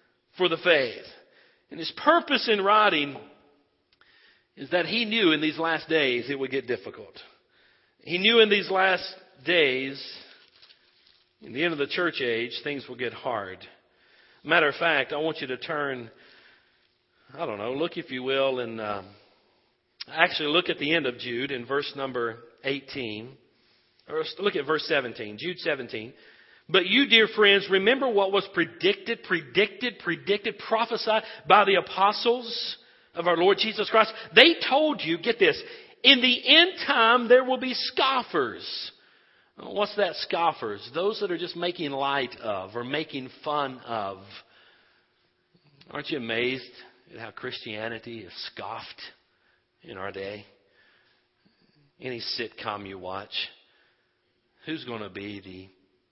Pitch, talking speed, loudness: 170 Hz, 150 wpm, -24 LUFS